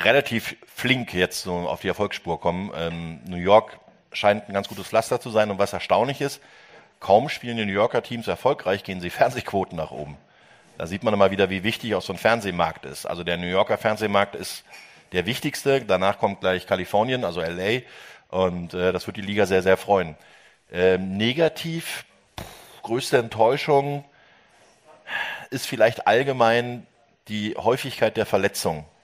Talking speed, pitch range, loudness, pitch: 165 wpm, 90-115 Hz, -23 LUFS, 100 Hz